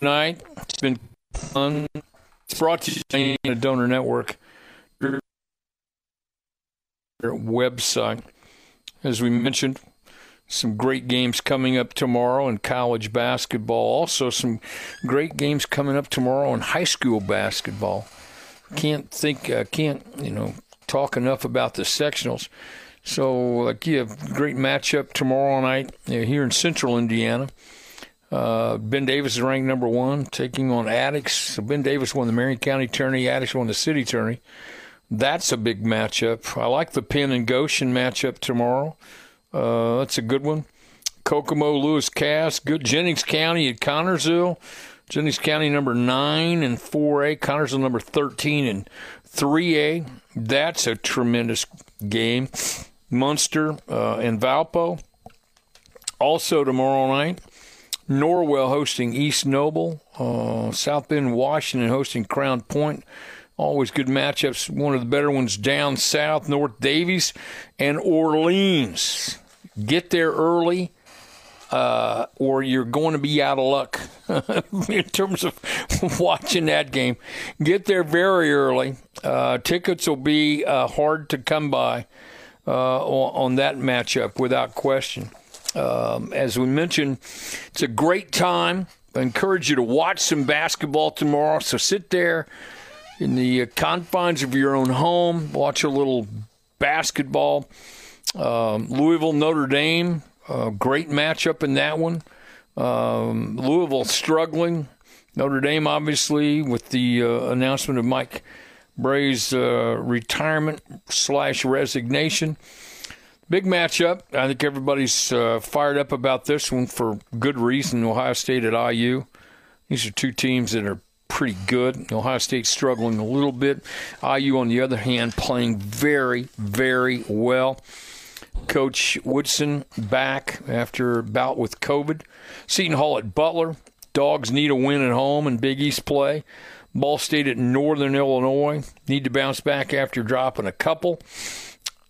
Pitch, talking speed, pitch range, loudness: 135 Hz, 140 wpm, 125-150 Hz, -22 LUFS